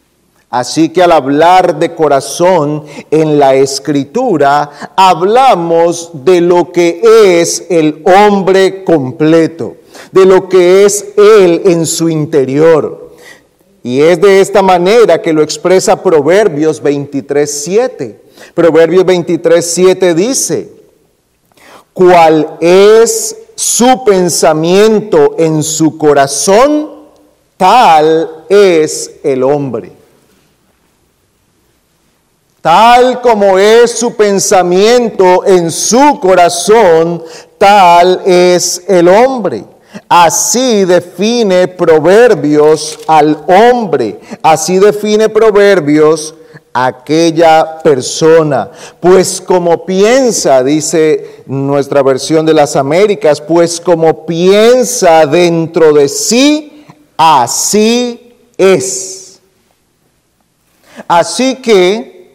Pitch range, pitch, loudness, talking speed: 160-215 Hz, 180 Hz, -7 LUFS, 85 wpm